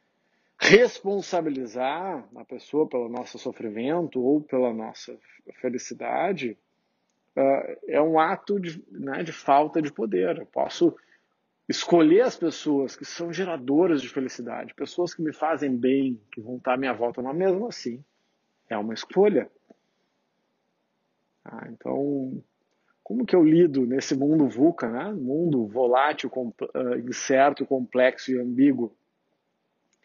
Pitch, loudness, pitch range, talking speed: 140 Hz, -25 LUFS, 125-175 Hz, 130 wpm